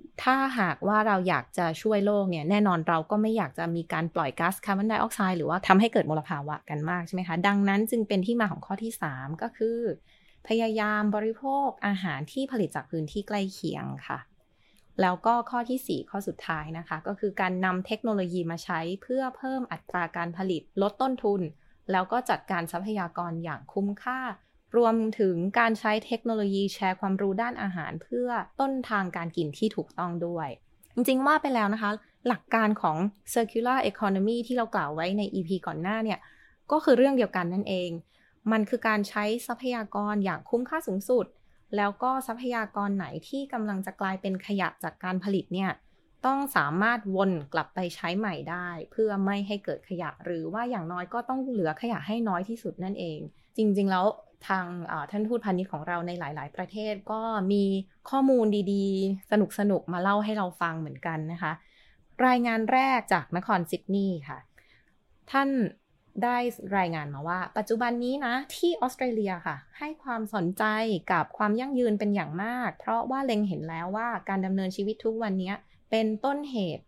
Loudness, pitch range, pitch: -29 LUFS, 180-230 Hz, 200 Hz